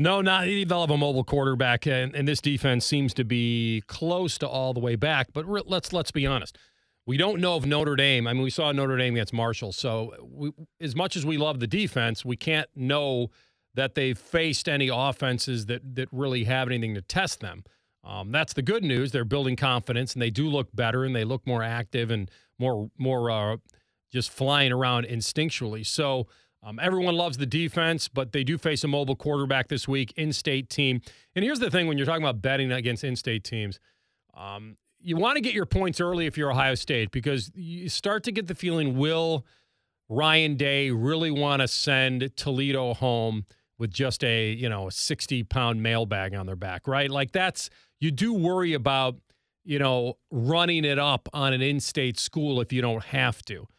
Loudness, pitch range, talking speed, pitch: -26 LUFS, 120-155 Hz, 200 wpm, 135 Hz